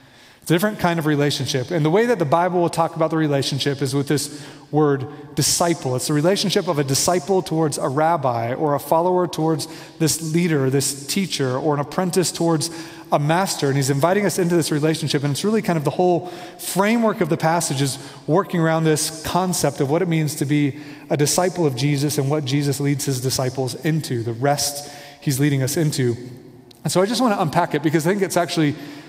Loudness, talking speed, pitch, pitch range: -20 LUFS, 210 wpm, 155 Hz, 145-170 Hz